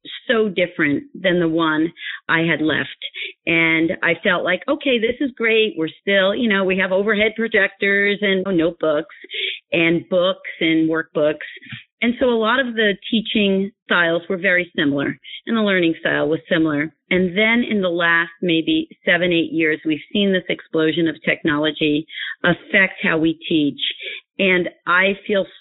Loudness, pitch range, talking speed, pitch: -18 LUFS, 165-220 Hz, 165 wpm, 190 Hz